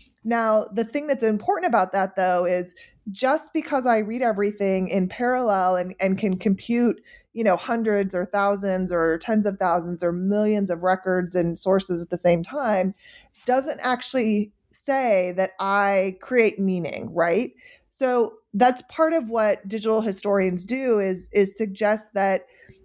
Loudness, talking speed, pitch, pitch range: -23 LUFS, 155 wpm, 205 Hz, 185-235 Hz